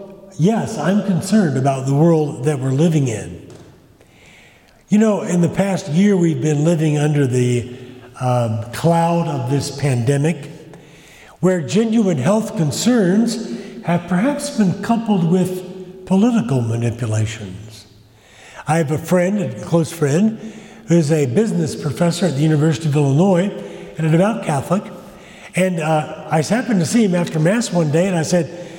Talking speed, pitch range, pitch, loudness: 150 wpm, 145-190 Hz, 170 Hz, -17 LUFS